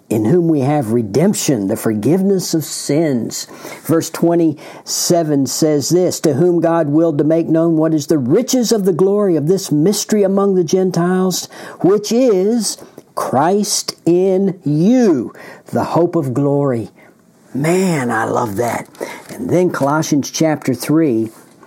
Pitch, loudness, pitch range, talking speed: 165 Hz, -15 LUFS, 150-185 Hz, 140 wpm